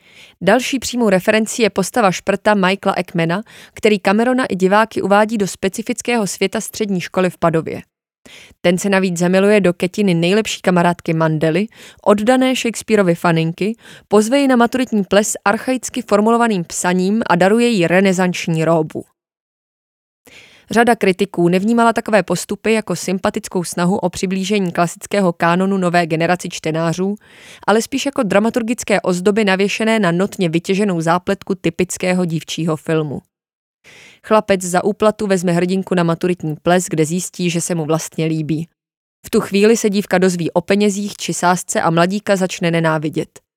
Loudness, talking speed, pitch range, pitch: -16 LUFS, 140 wpm, 175-215 Hz, 190 Hz